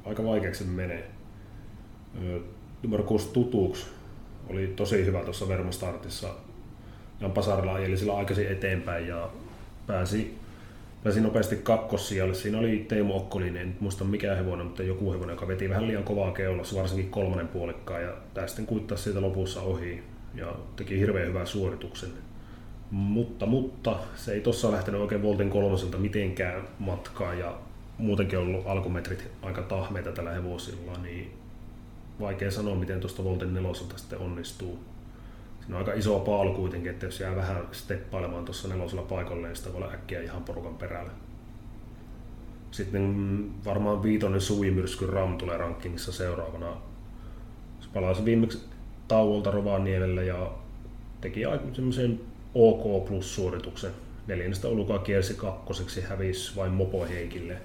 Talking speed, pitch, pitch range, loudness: 135 wpm, 100 Hz, 95-110 Hz, -30 LUFS